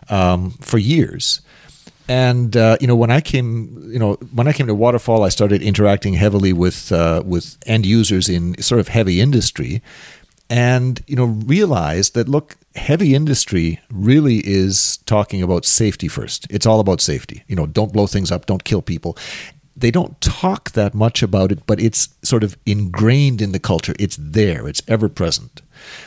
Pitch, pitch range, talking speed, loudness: 110 Hz, 95-125 Hz, 180 wpm, -16 LUFS